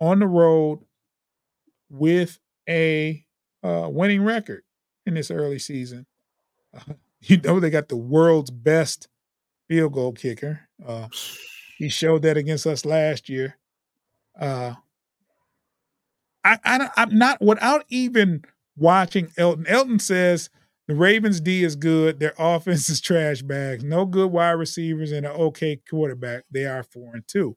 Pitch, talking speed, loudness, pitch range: 160 Hz, 140 wpm, -21 LUFS, 145-180 Hz